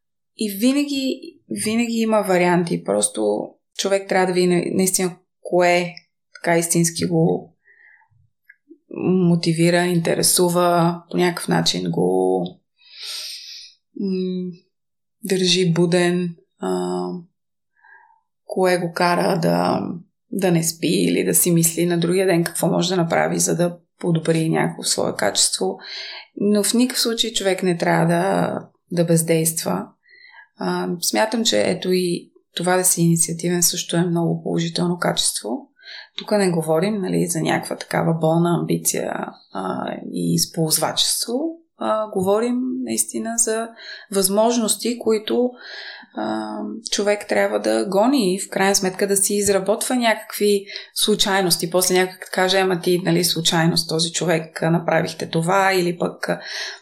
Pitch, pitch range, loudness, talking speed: 180 Hz, 165-205 Hz, -19 LUFS, 125 wpm